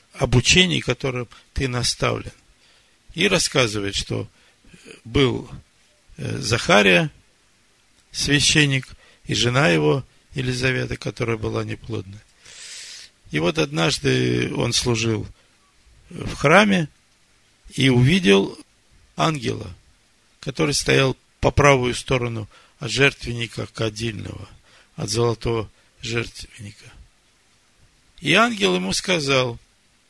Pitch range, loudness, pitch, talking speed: 110-140 Hz, -20 LUFS, 120 Hz, 85 wpm